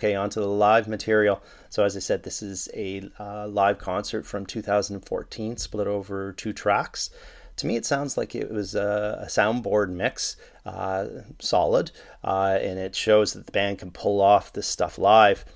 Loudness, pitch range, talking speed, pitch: -25 LUFS, 100-105 Hz, 175 wpm, 100 Hz